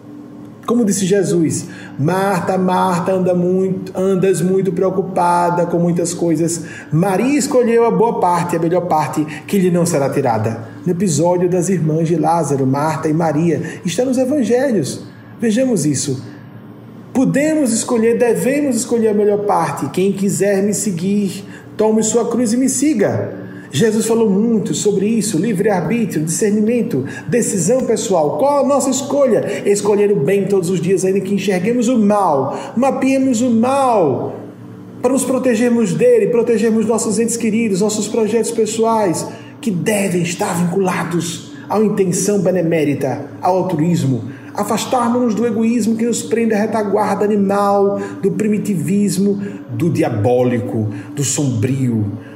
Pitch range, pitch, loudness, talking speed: 165-225 Hz, 195 Hz, -16 LUFS, 140 wpm